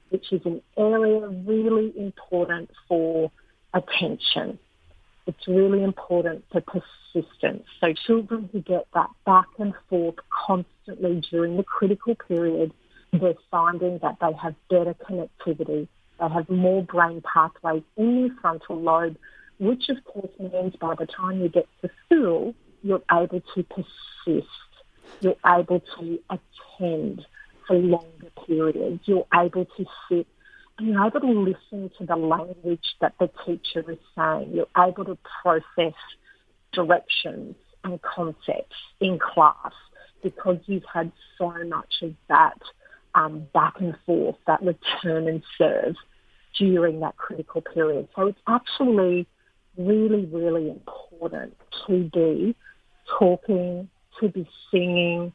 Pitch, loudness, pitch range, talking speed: 180 Hz, -24 LUFS, 170-195 Hz, 130 wpm